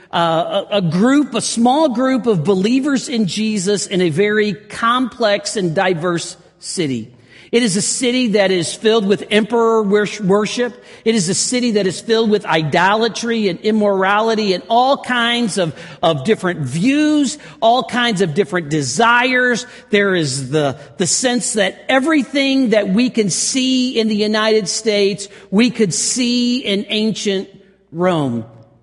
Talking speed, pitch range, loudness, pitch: 150 wpm, 185-235 Hz, -16 LUFS, 210 Hz